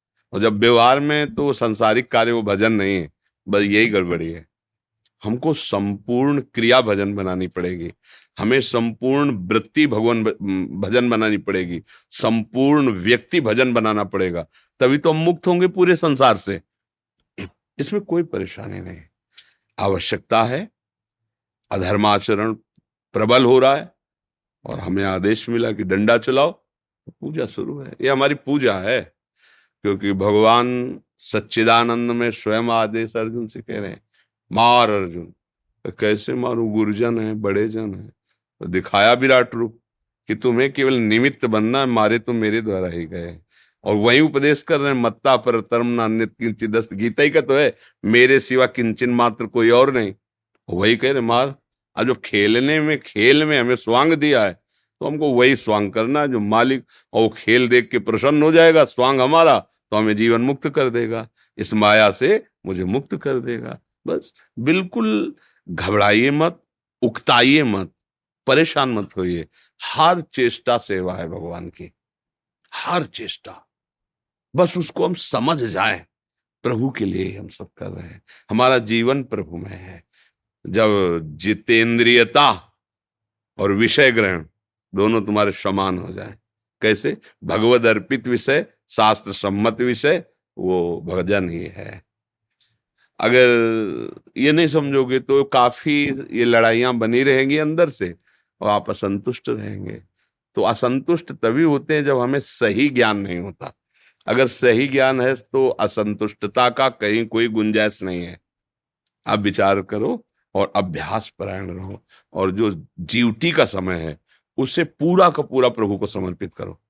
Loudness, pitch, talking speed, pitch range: -18 LUFS, 115 Hz, 145 wpm, 105-130 Hz